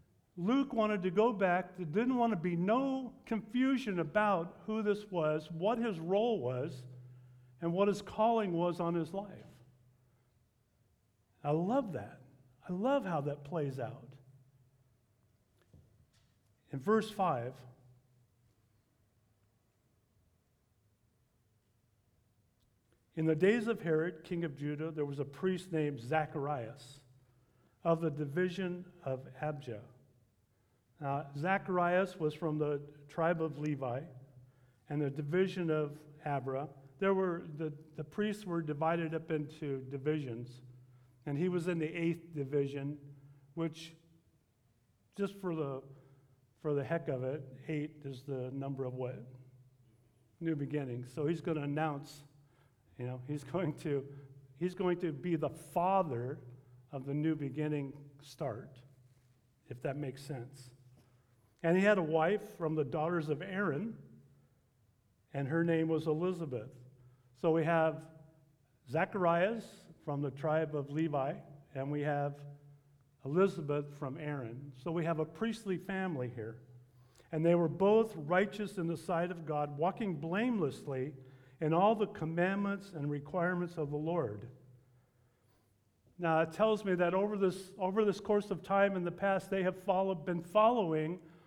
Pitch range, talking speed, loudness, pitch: 130-175 Hz, 135 wpm, -35 LUFS, 150 Hz